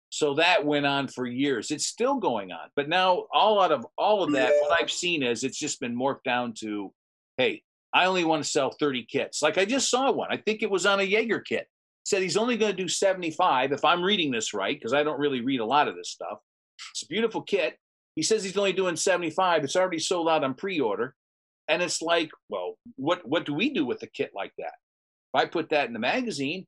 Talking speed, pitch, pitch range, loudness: 245 wpm, 175 Hz, 145-200 Hz, -26 LUFS